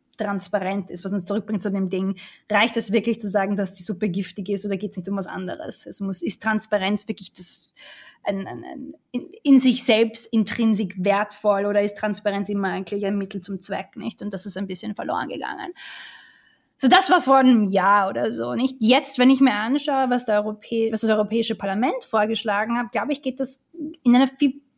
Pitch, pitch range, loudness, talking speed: 210 Hz, 200-245 Hz, -22 LUFS, 215 wpm